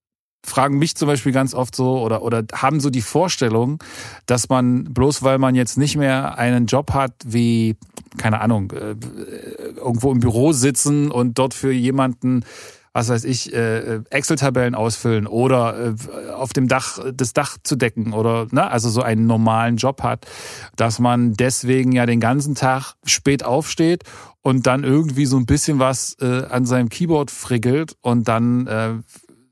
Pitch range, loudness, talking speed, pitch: 115-135 Hz, -18 LUFS, 160 wpm, 125 Hz